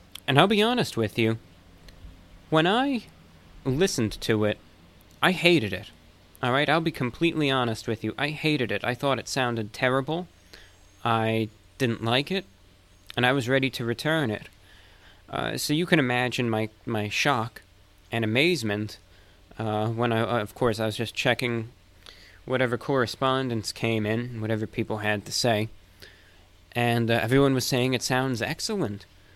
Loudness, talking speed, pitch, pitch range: -26 LUFS, 155 wpm, 115 Hz, 100-130 Hz